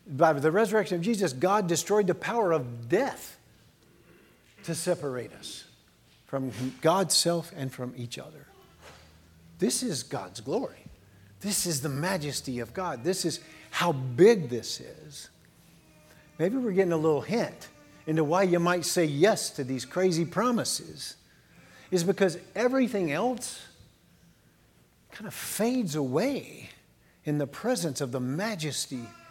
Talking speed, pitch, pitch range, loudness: 135 wpm, 160 Hz, 130-190 Hz, -28 LUFS